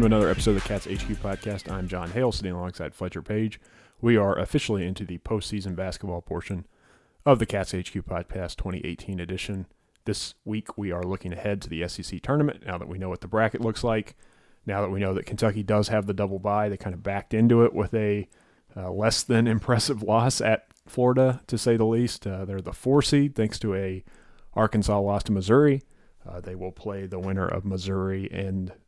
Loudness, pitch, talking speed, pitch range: -26 LUFS, 100 Hz, 210 wpm, 95-110 Hz